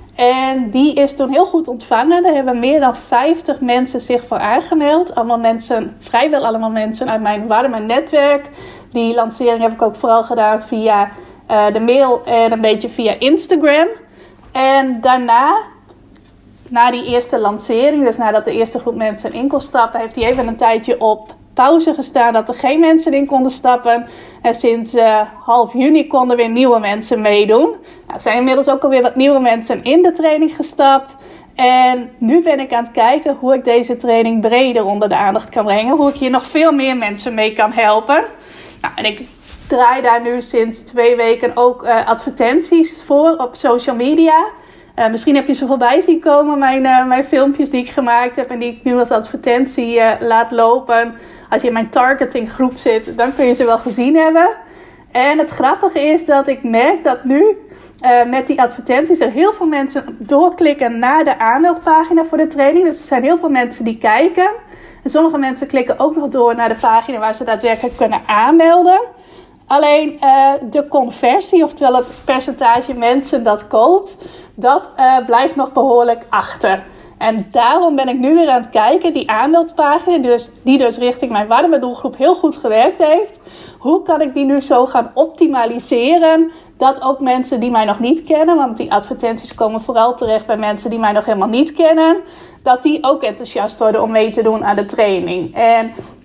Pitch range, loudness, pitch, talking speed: 235-295 Hz, -13 LUFS, 255 Hz, 190 wpm